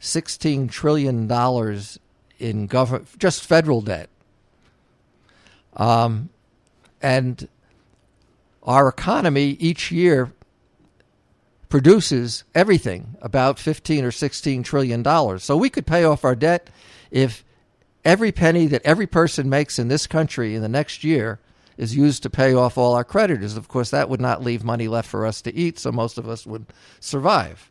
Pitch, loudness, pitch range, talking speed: 130 Hz, -20 LUFS, 120-155 Hz, 150 wpm